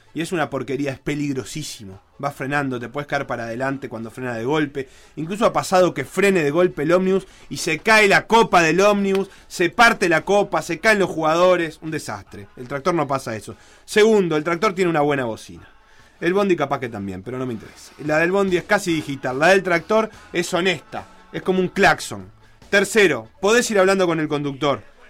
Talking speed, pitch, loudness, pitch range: 205 wpm, 155 Hz, -19 LUFS, 135-185 Hz